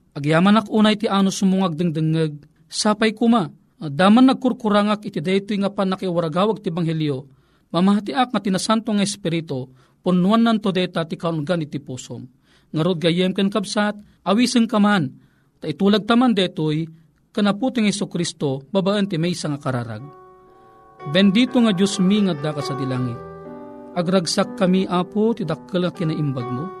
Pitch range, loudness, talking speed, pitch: 160-210 Hz, -20 LUFS, 145 wpm, 185 Hz